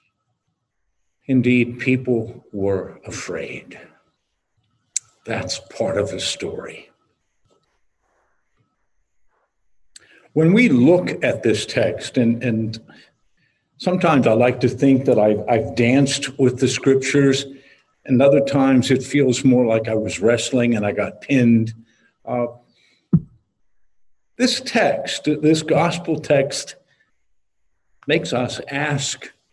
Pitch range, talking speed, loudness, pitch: 115-140 Hz, 105 wpm, -19 LUFS, 125 Hz